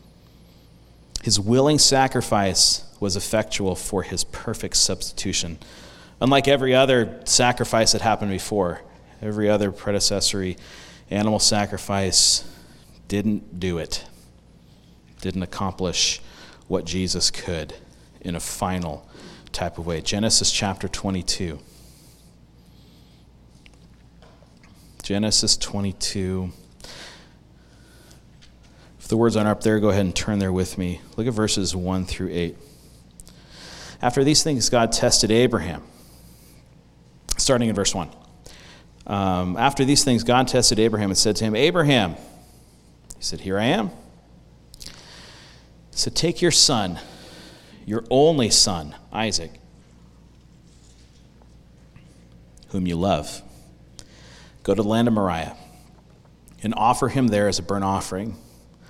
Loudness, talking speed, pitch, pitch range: -21 LUFS, 115 wpm, 100 Hz, 80-110 Hz